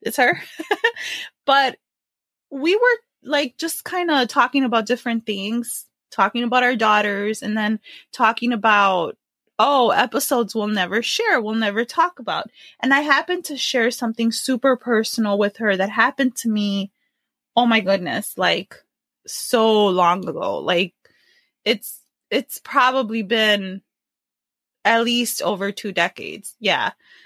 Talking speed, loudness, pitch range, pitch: 135 wpm, -20 LUFS, 210-270 Hz, 235 Hz